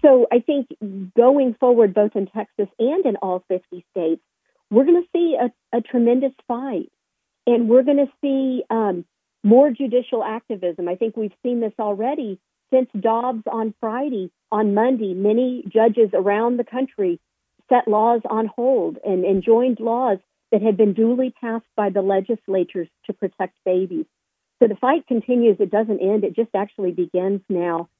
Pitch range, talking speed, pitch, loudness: 200-250 Hz, 165 wpm, 225 Hz, -20 LUFS